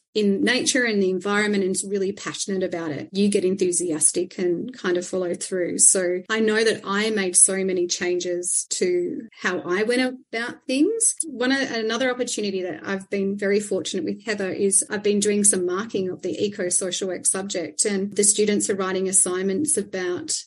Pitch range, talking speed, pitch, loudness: 185-220 Hz, 185 wpm, 195 Hz, -22 LUFS